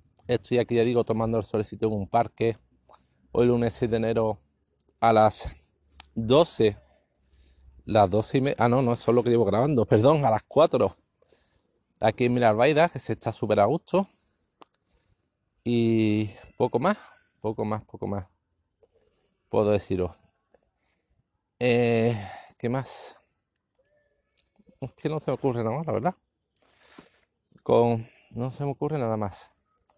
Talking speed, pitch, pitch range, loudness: 145 wpm, 115 Hz, 105-120 Hz, -25 LUFS